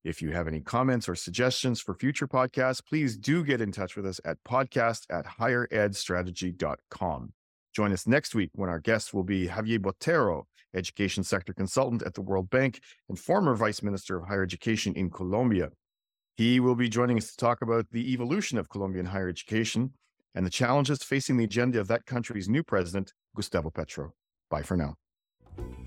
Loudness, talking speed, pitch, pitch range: -29 LUFS, 180 wpm, 110 Hz, 95-125 Hz